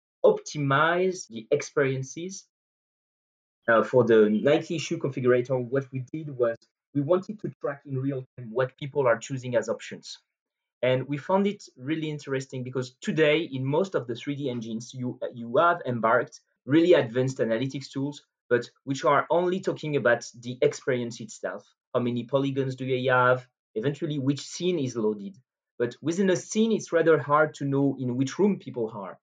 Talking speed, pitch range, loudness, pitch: 170 wpm, 125-155 Hz, -26 LUFS, 135 Hz